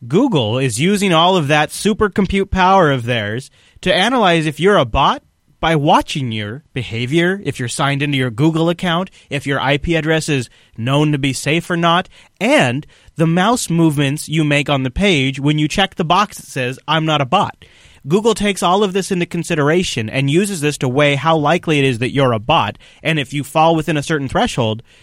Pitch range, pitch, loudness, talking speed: 135-175 Hz, 155 Hz, -16 LUFS, 210 wpm